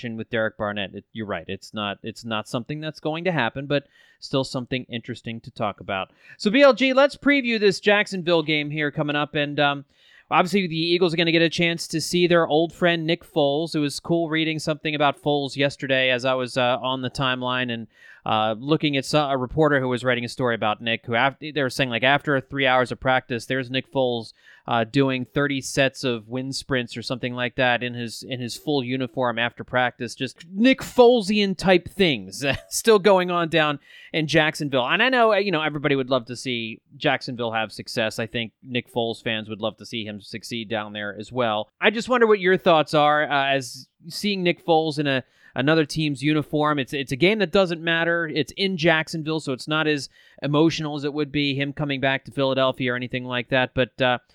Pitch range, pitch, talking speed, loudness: 125-160 Hz, 140 Hz, 220 wpm, -22 LUFS